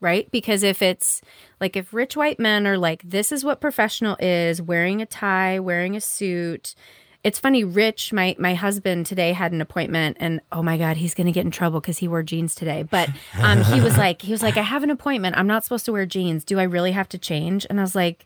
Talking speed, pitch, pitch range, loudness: 245 wpm, 185 Hz, 170-210 Hz, -21 LUFS